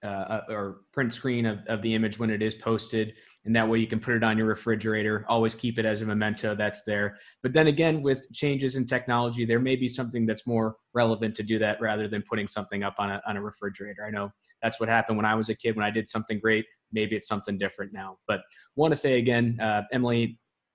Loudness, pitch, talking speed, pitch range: -27 LUFS, 110 Hz, 245 wpm, 105-120 Hz